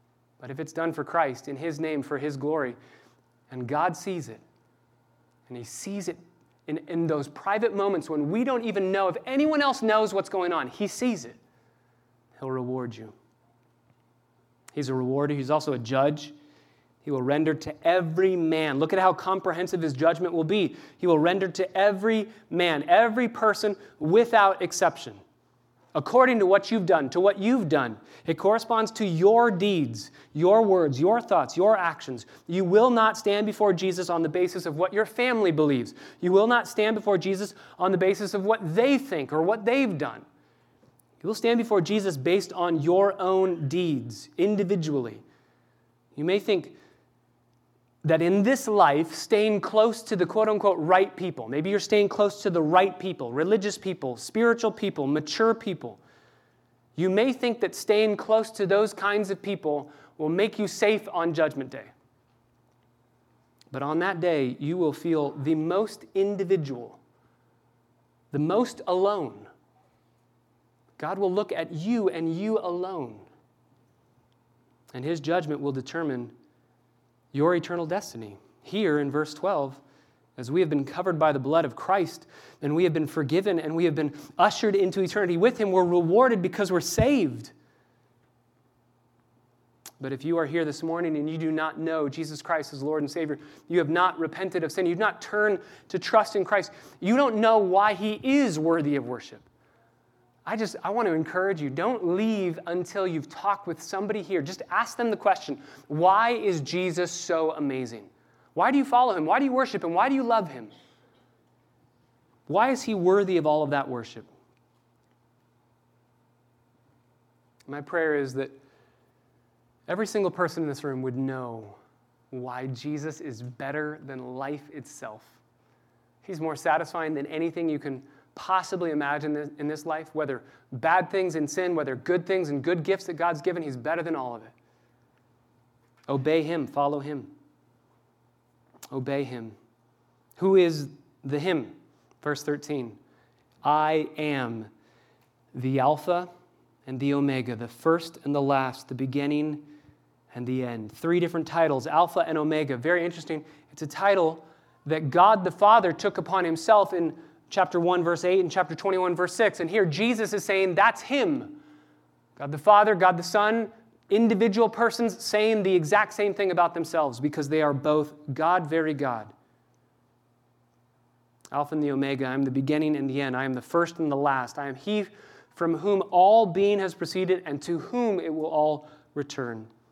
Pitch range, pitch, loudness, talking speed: 135-195 Hz, 160 Hz, -25 LUFS, 170 wpm